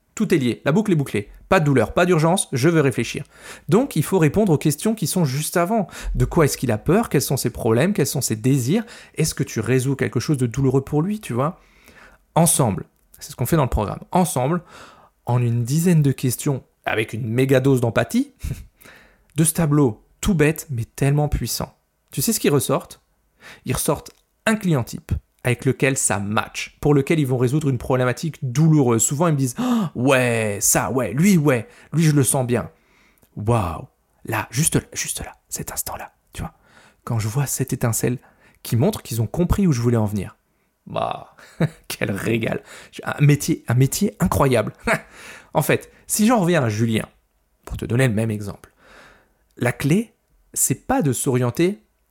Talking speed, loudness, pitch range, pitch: 195 wpm, -20 LUFS, 125-170 Hz, 140 Hz